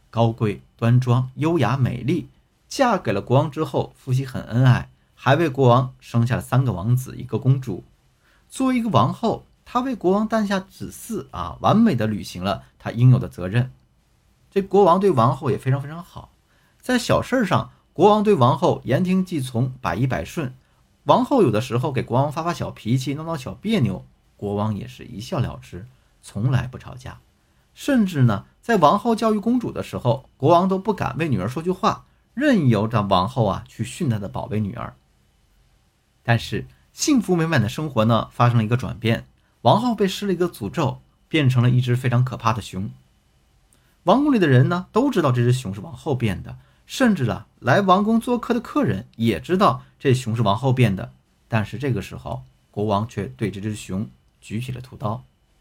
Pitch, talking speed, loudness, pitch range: 125 Hz, 275 characters per minute, -21 LUFS, 110-170 Hz